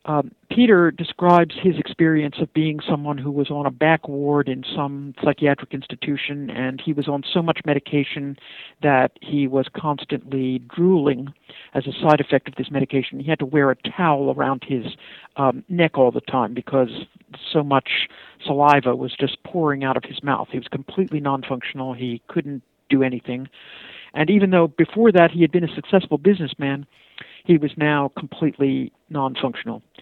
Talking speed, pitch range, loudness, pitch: 170 wpm, 135-160 Hz, -21 LUFS, 145 Hz